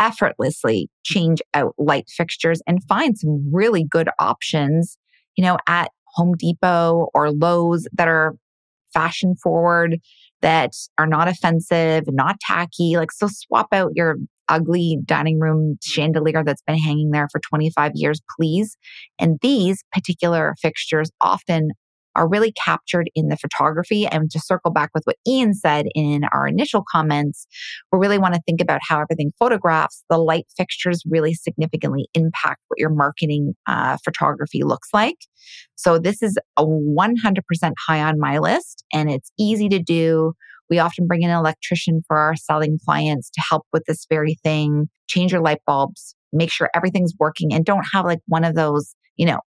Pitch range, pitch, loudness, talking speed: 155-175 Hz, 165 Hz, -19 LUFS, 165 wpm